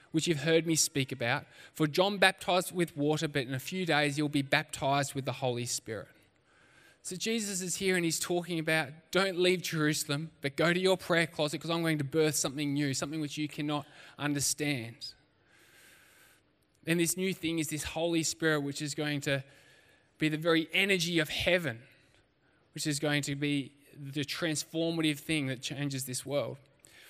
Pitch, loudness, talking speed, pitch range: 150 Hz, -31 LUFS, 180 wpm, 140-165 Hz